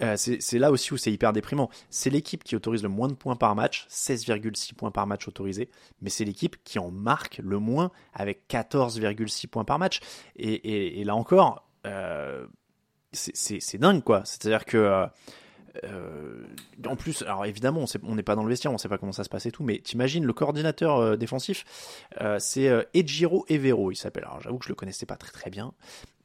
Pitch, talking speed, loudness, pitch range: 115 Hz, 215 wpm, -27 LUFS, 105-135 Hz